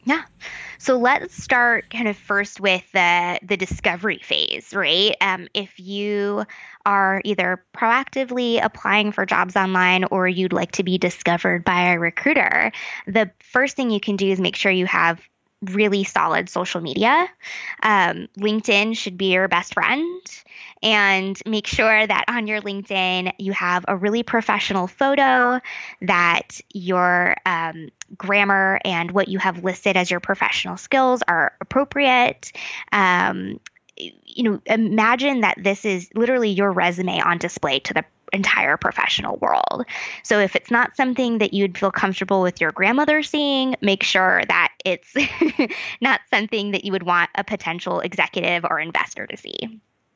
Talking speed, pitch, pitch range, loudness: 155 wpm, 200 Hz, 185-235 Hz, -19 LUFS